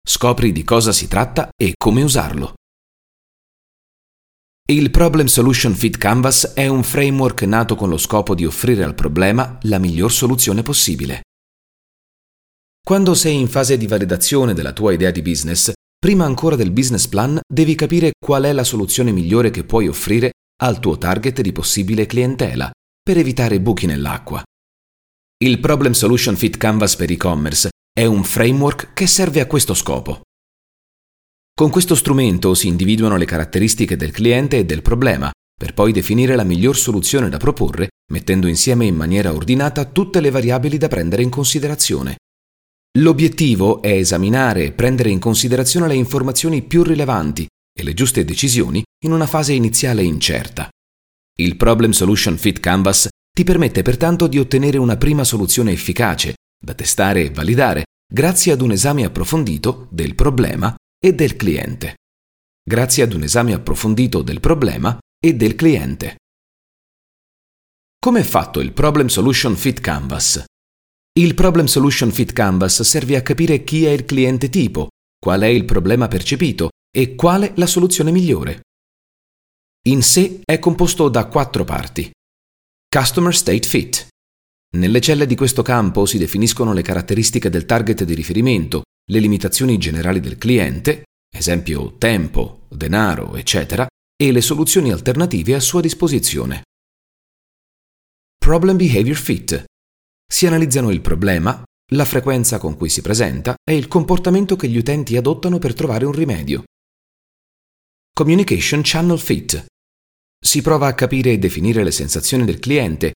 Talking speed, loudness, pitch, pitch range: 145 wpm, -15 LUFS, 115 Hz, 90-140 Hz